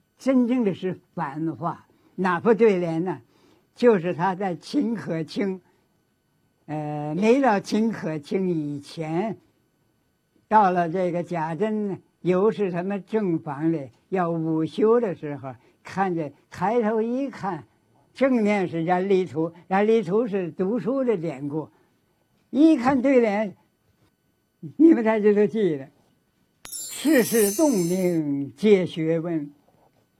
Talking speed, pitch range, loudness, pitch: 170 characters per minute, 165-220 Hz, -23 LUFS, 185 Hz